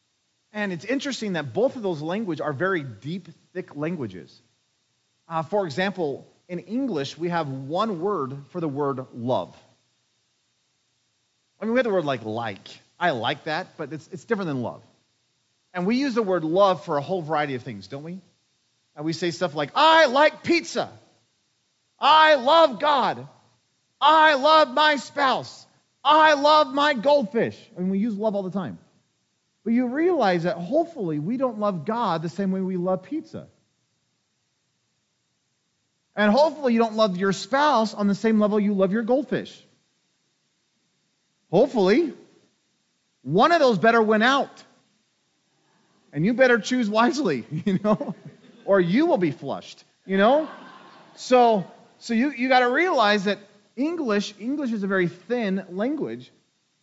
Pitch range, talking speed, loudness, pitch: 165-255 Hz, 160 wpm, -22 LUFS, 205 Hz